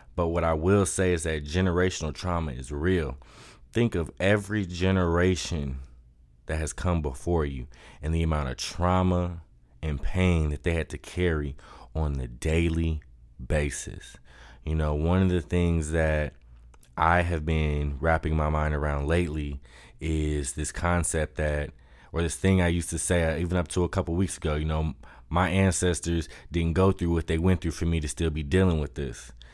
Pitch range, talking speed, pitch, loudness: 75-90 Hz, 180 wpm, 80 Hz, -27 LUFS